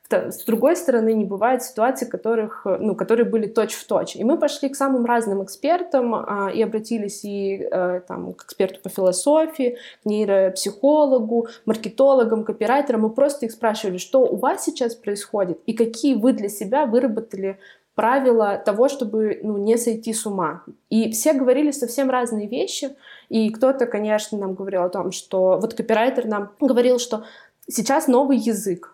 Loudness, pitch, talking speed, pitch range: -21 LUFS, 225 Hz, 165 wpm, 205-255 Hz